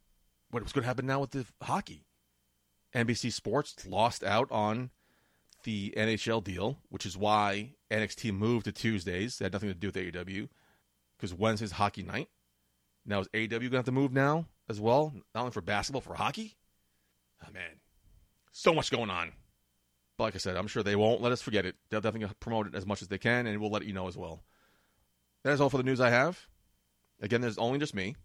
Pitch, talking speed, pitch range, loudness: 105 Hz, 210 wpm, 95-120 Hz, -32 LUFS